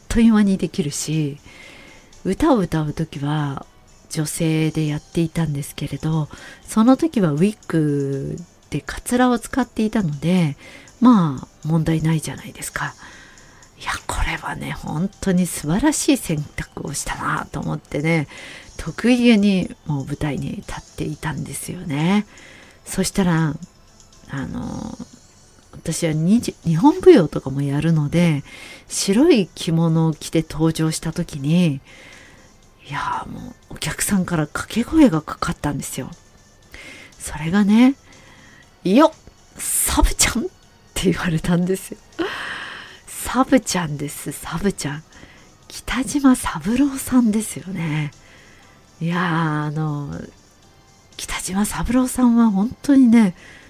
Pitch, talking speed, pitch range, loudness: 170 Hz, 255 characters per minute, 150-215 Hz, -20 LUFS